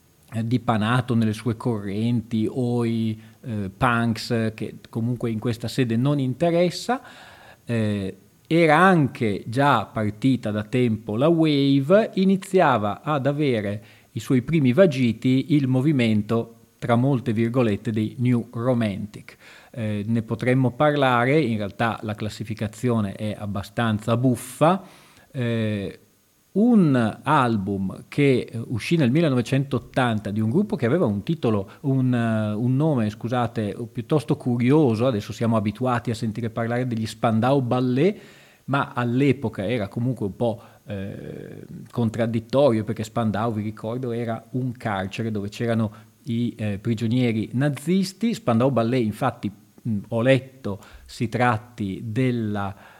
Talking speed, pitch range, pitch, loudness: 125 wpm, 110-130 Hz, 120 Hz, -23 LUFS